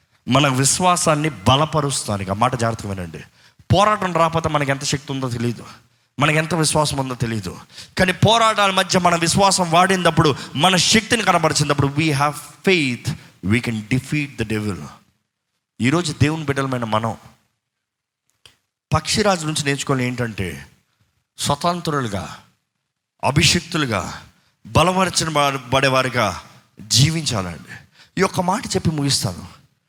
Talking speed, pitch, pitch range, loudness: 105 wpm, 140 Hz, 115-165 Hz, -18 LUFS